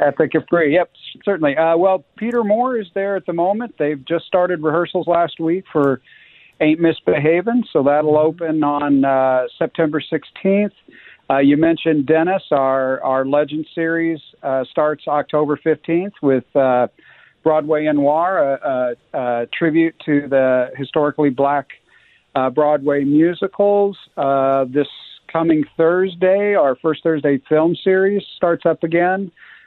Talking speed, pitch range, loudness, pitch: 140 wpm, 145-175 Hz, -17 LUFS, 160 Hz